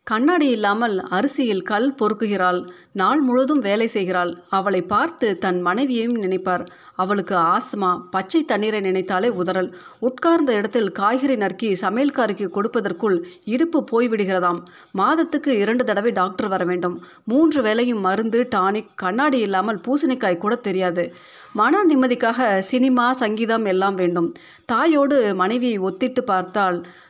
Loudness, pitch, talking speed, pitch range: -20 LUFS, 210 Hz, 115 wpm, 185-250 Hz